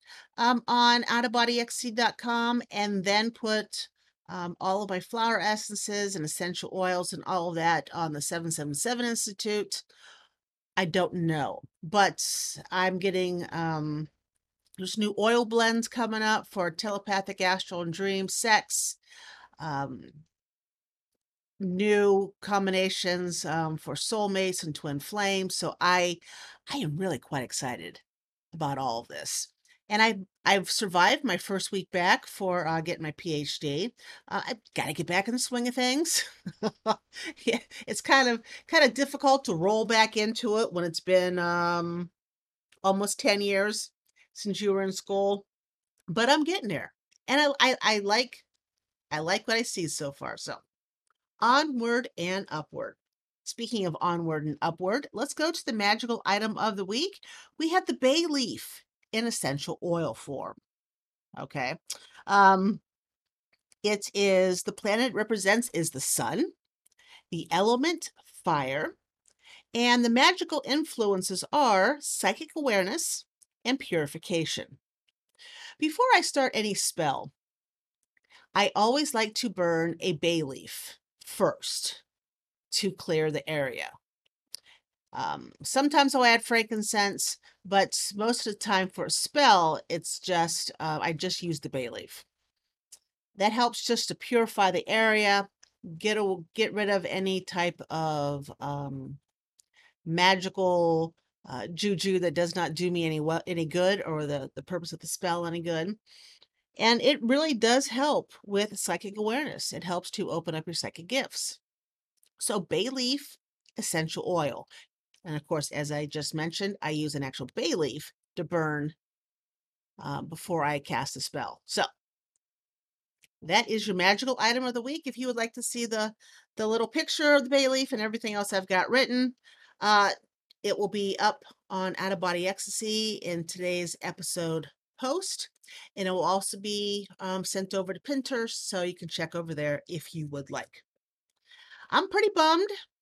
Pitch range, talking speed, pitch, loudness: 175-240 Hz, 155 wpm, 200 Hz, -28 LUFS